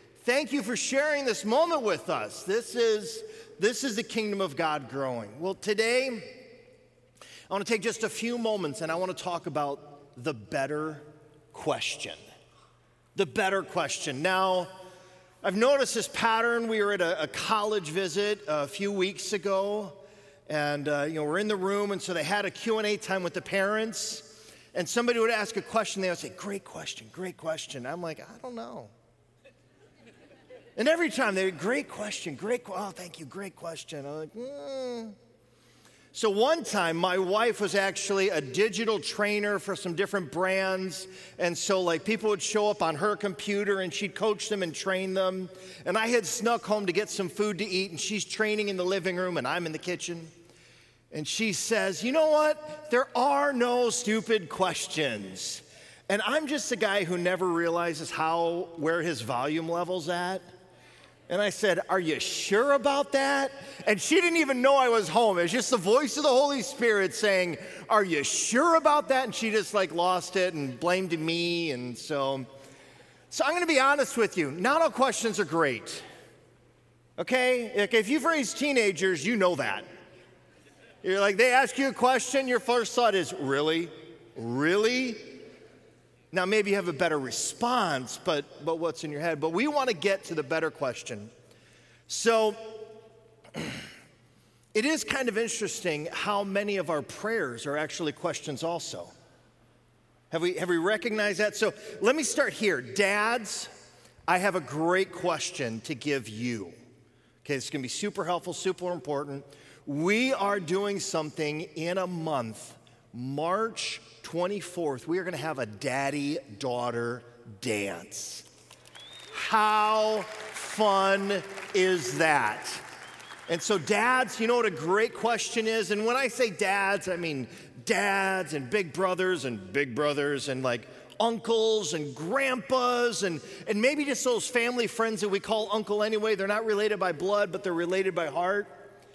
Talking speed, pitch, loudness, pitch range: 175 wpm, 195 Hz, -28 LUFS, 165-225 Hz